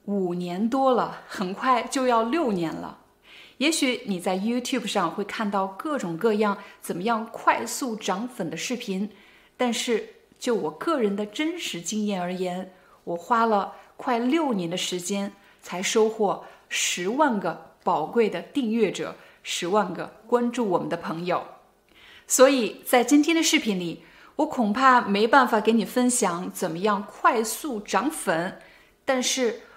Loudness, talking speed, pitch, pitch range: -25 LUFS, 225 characters per minute, 220 Hz, 195-255 Hz